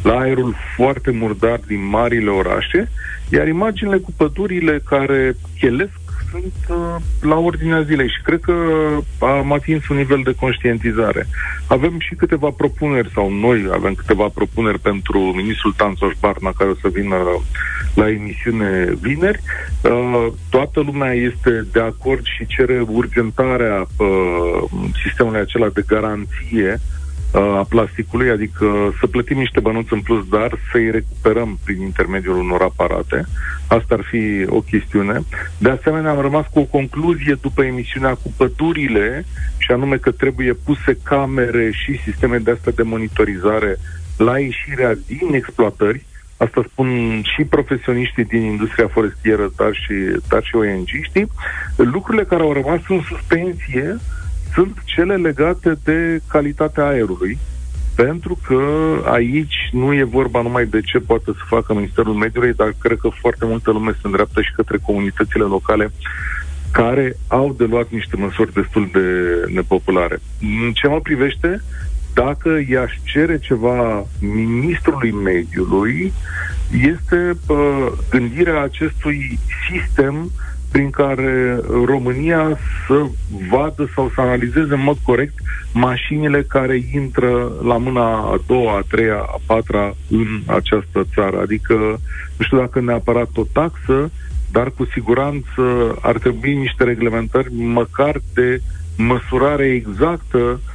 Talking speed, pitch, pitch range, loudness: 135 wpm, 120 Hz, 105-140 Hz, -17 LUFS